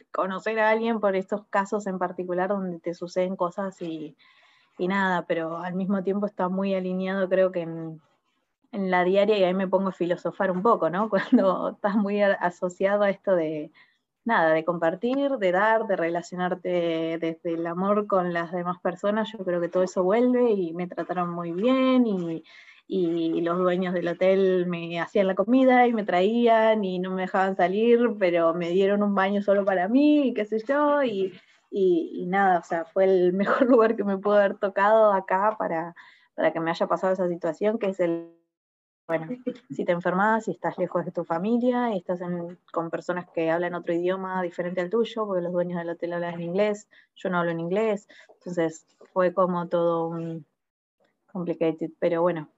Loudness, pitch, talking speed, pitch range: -25 LUFS, 185 Hz, 195 wpm, 175-210 Hz